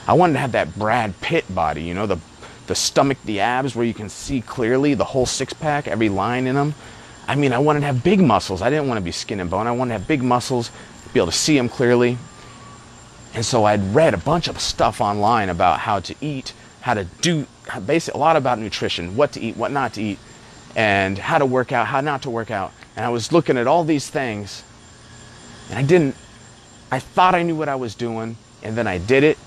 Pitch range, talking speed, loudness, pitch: 115-140 Hz, 240 wpm, -20 LUFS, 120 Hz